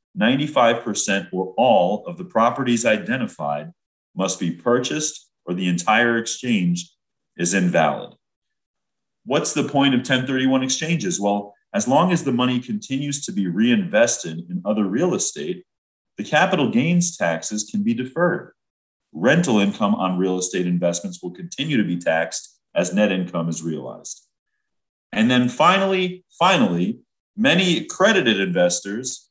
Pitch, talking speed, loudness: 125 Hz, 135 wpm, -20 LUFS